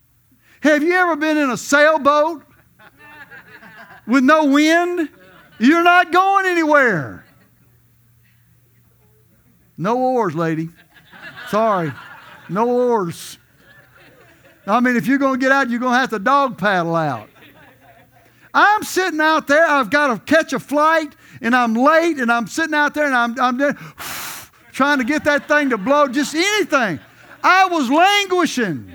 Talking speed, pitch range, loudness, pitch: 145 wpm, 205-310 Hz, -16 LUFS, 270 Hz